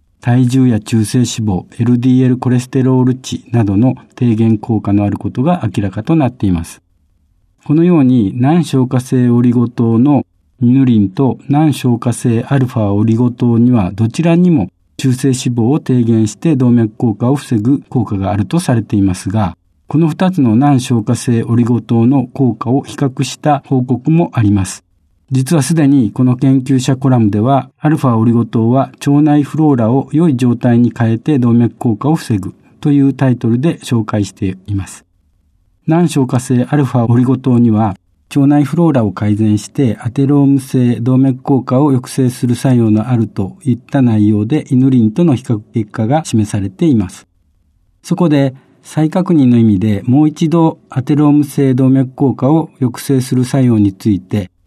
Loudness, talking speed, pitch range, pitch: -12 LUFS, 330 characters per minute, 110-140 Hz, 125 Hz